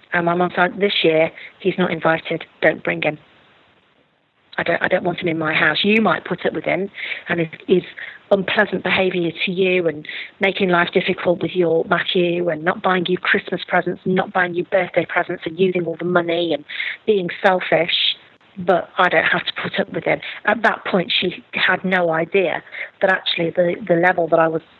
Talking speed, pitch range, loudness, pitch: 205 wpm, 165-185 Hz, -19 LUFS, 180 Hz